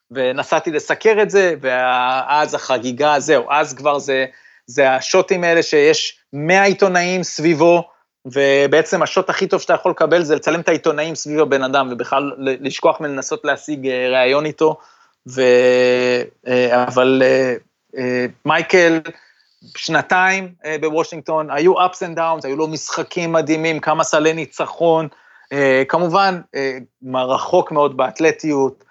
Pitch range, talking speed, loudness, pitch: 130-170 Hz, 120 wpm, -16 LUFS, 155 Hz